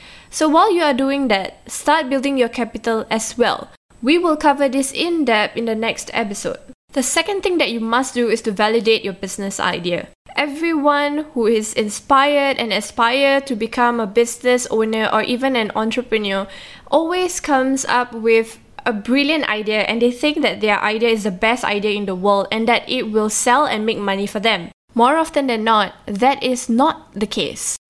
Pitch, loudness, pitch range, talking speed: 235 Hz, -18 LUFS, 220-275 Hz, 190 wpm